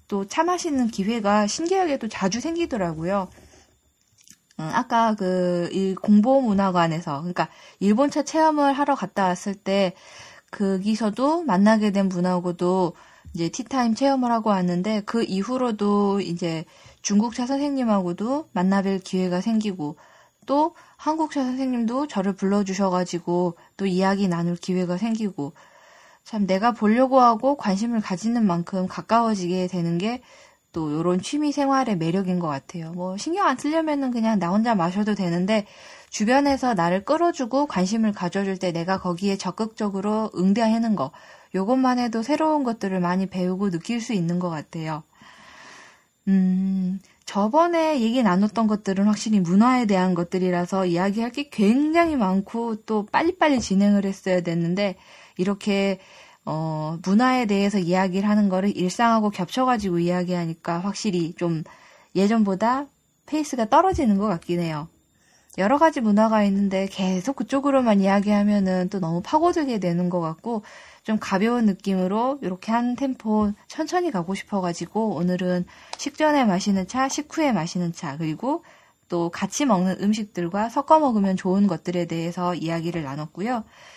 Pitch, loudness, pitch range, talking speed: 200 Hz, -23 LUFS, 180-240 Hz, 325 characters per minute